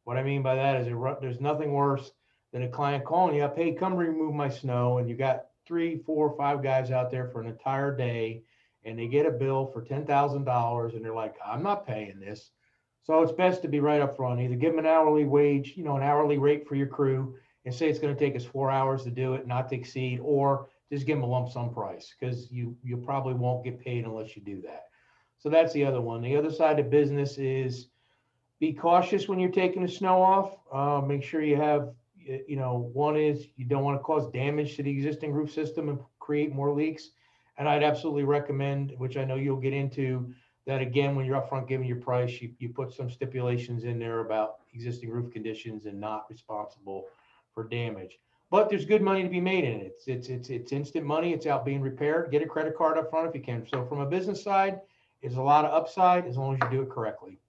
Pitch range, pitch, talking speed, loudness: 125-150 Hz, 140 Hz, 235 wpm, -28 LUFS